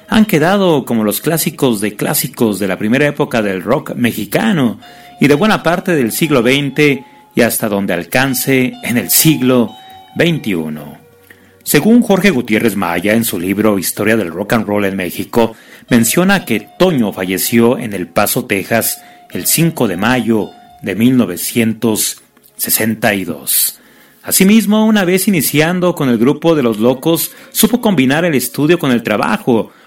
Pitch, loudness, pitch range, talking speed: 130 Hz, -13 LUFS, 110-170 Hz, 150 wpm